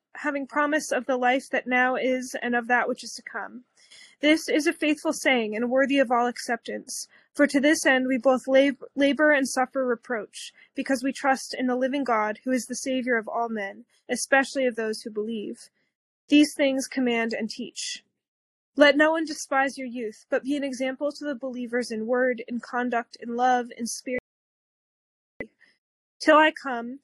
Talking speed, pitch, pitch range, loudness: 185 wpm, 260 Hz, 240-280 Hz, -25 LUFS